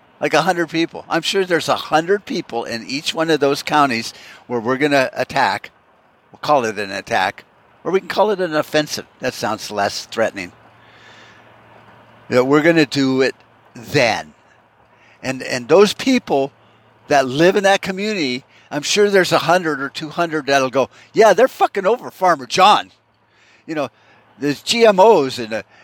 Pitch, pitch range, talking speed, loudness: 150 Hz, 130-185 Hz, 175 wpm, -17 LUFS